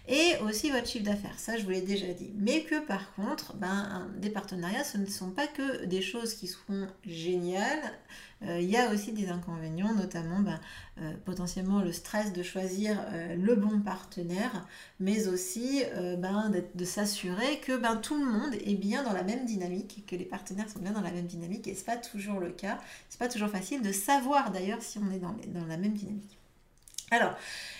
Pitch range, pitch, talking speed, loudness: 185-225 Hz, 200 Hz, 210 wpm, -33 LUFS